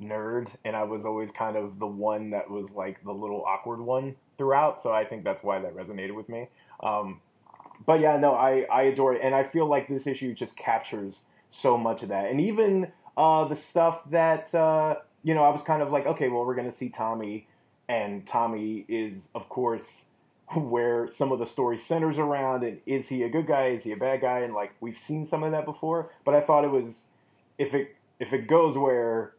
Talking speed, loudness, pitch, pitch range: 225 wpm, -27 LUFS, 130 Hz, 110-150 Hz